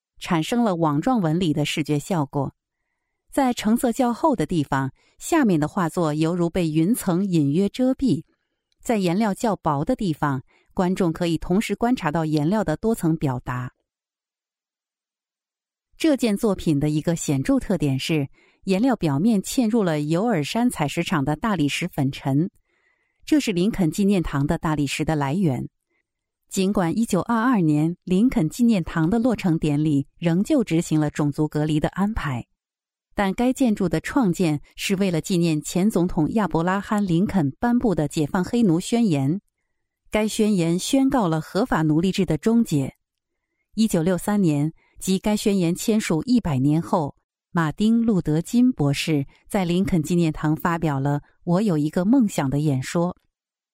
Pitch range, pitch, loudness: 155-215 Hz, 175 Hz, -22 LUFS